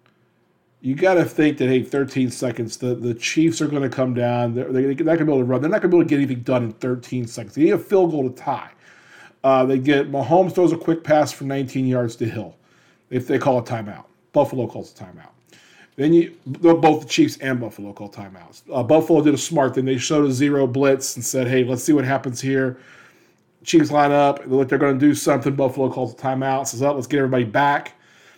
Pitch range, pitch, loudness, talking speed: 125-150 Hz, 135 Hz, -19 LUFS, 245 wpm